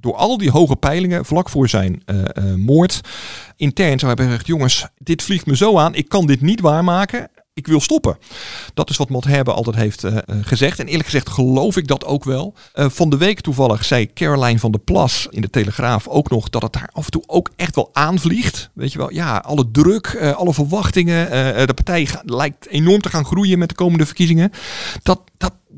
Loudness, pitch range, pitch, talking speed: -16 LUFS, 125-175 Hz, 145 Hz, 220 wpm